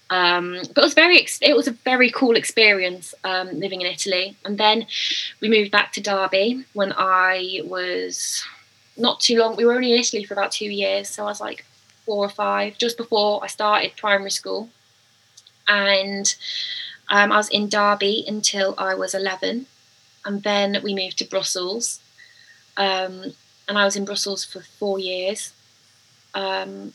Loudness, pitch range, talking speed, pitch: -20 LUFS, 185-215 Hz, 170 wpm, 200 Hz